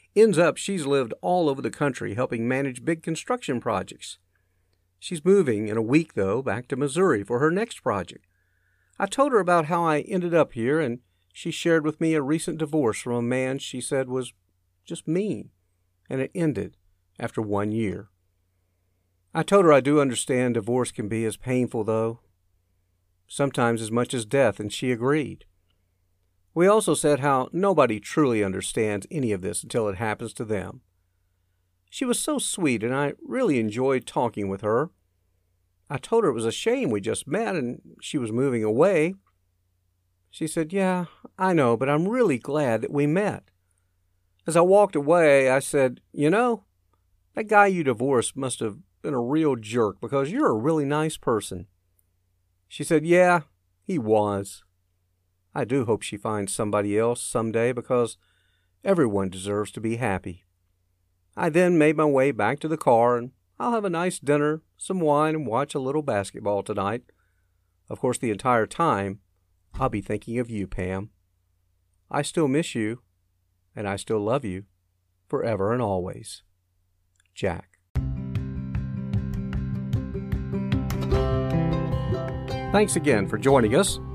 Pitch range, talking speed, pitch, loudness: 90-145 Hz, 160 wpm, 115 Hz, -24 LUFS